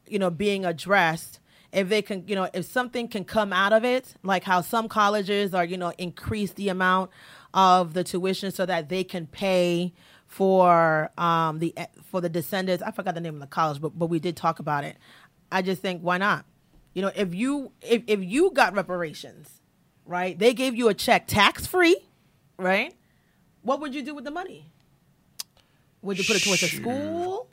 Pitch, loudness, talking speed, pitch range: 185 Hz, -25 LUFS, 200 wpm, 170-210 Hz